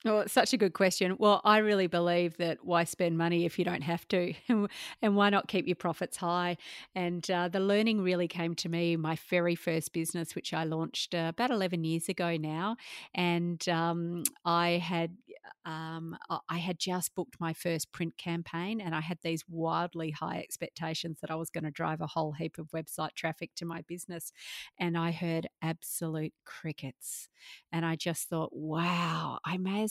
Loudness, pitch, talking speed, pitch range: -32 LUFS, 170 Hz, 190 wpm, 165-180 Hz